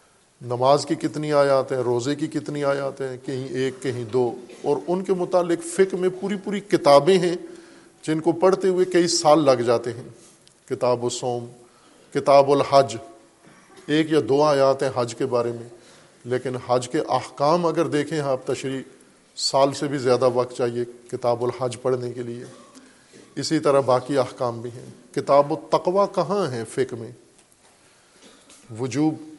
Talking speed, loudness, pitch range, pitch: 160 wpm, -22 LUFS, 125-160 Hz, 140 Hz